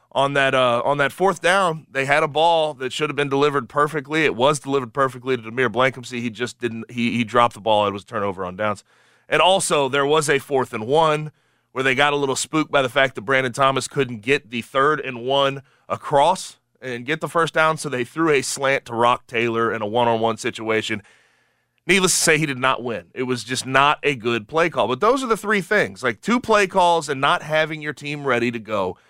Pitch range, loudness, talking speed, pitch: 120-155 Hz, -20 LUFS, 235 wpm, 135 Hz